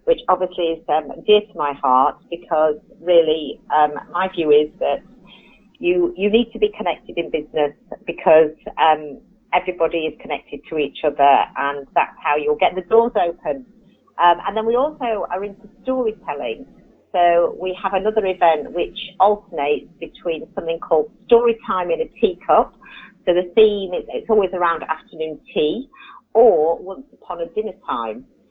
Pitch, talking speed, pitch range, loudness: 185 Hz, 160 wpm, 155-220 Hz, -19 LUFS